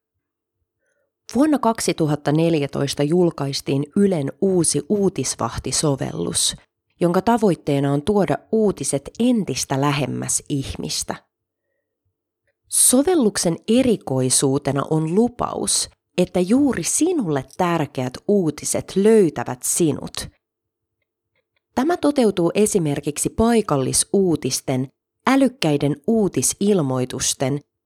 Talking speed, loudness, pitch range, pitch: 65 wpm, -20 LUFS, 140-210 Hz, 155 Hz